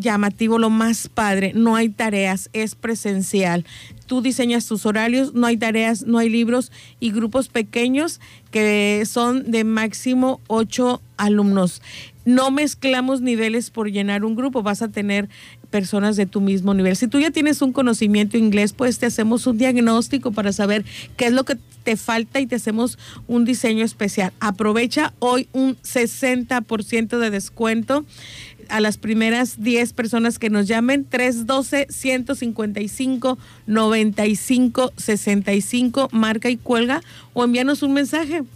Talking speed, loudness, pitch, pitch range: 145 wpm, -19 LUFS, 230 Hz, 215-250 Hz